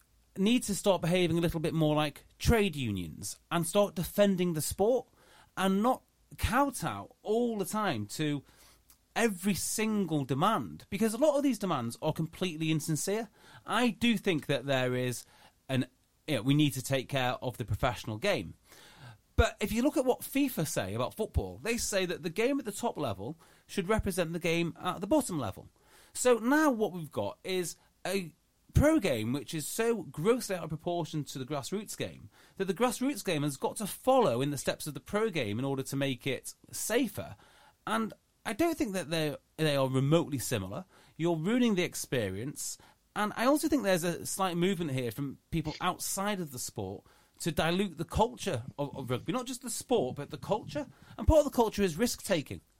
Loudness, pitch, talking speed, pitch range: -31 LUFS, 170 Hz, 195 wpm, 140-210 Hz